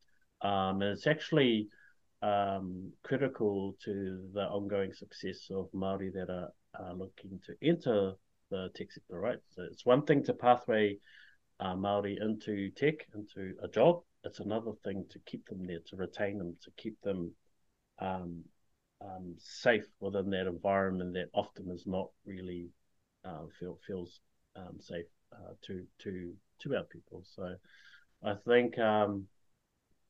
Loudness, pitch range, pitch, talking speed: -35 LUFS, 95-105 Hz, 100 Hz, 140 wpm